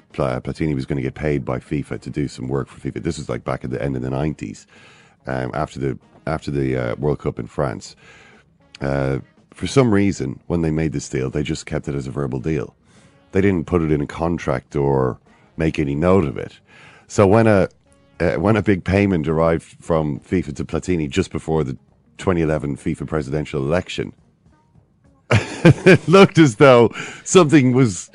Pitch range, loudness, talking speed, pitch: 70-95 Hz, -19 LUFS, 195 wpm, 80 Hz